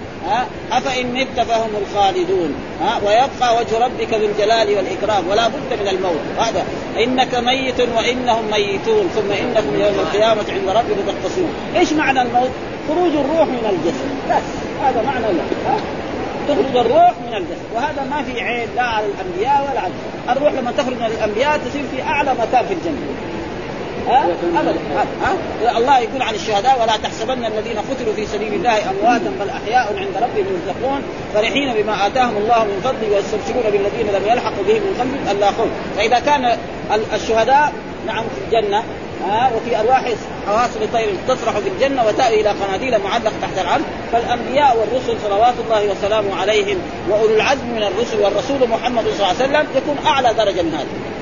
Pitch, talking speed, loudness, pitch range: 240 Hz, 160 wpm, -17 LUFS, 215-285 Hz